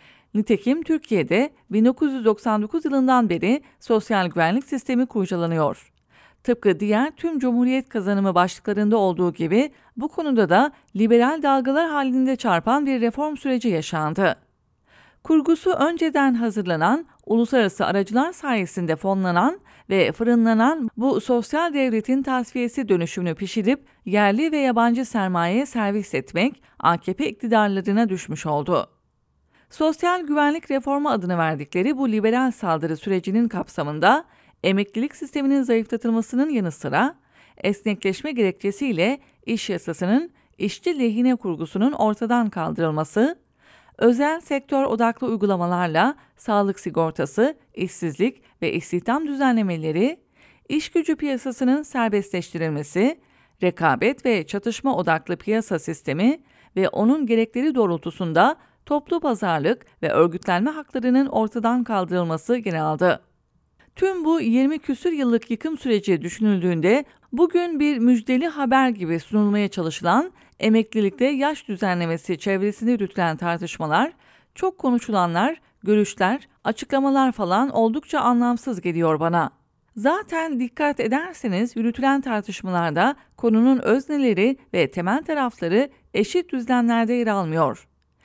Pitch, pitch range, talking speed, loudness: 230 Hz, 190-270 Hz, 105 wpm, -22 LUFS